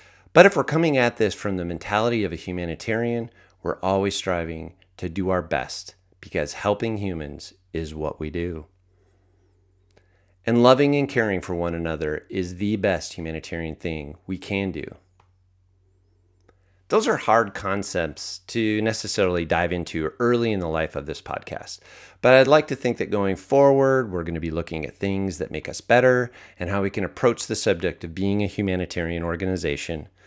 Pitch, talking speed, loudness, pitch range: 95 Hz, 170 wpm, -23 LUFS, 85-105 Hz